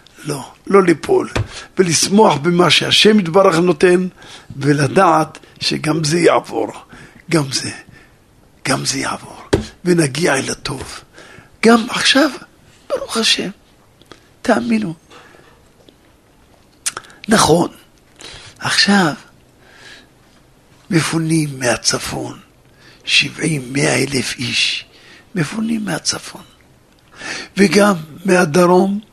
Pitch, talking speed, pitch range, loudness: 170 Hz, 75 wpm, 150-195 Hz, -15 LUFS